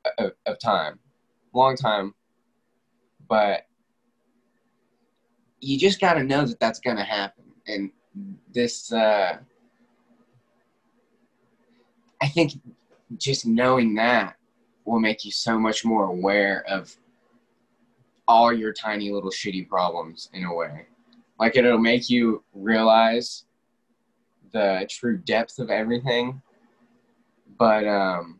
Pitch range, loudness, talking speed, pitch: 105-130 Hz, -23 LUFS, 110 wpm, 115 Hz